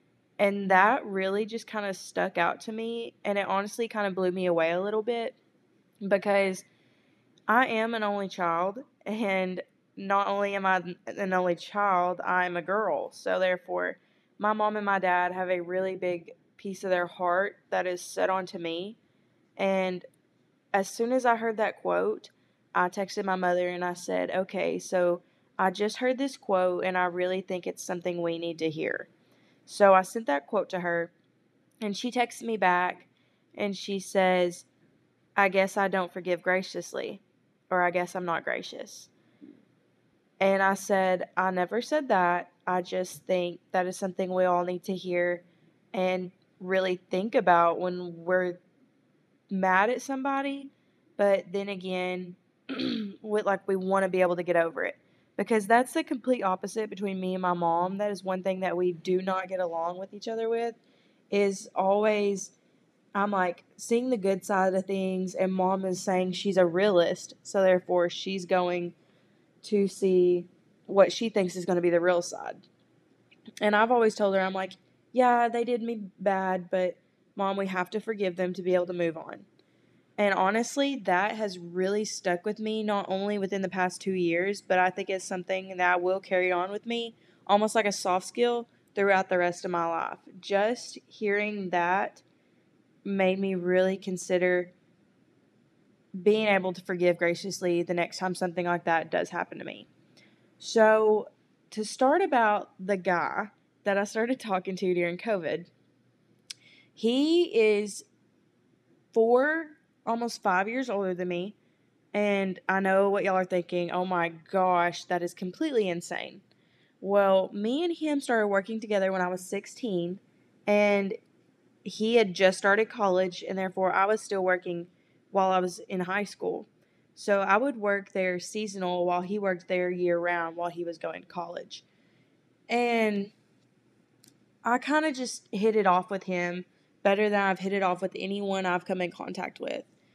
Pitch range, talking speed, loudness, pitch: 180-210 Hz, 175 wpm, -28 LUFS, 190 Hz